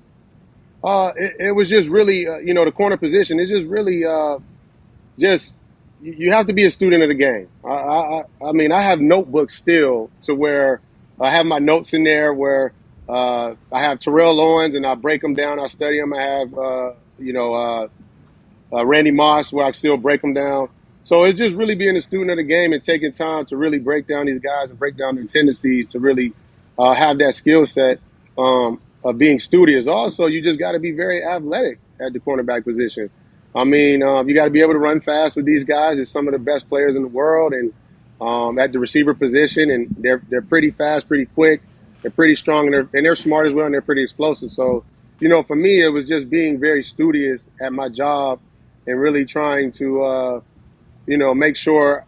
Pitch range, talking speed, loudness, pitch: 130-160 Hz, 220 wpm, -17 LUFS, 145 Hz